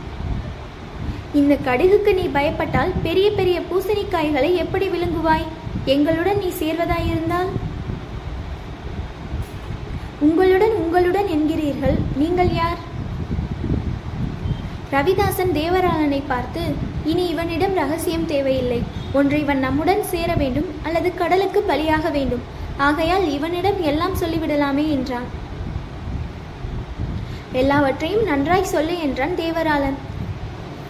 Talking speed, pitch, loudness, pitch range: 85 wpm, 330 Hz, -20 LUFS, 290-365 Hz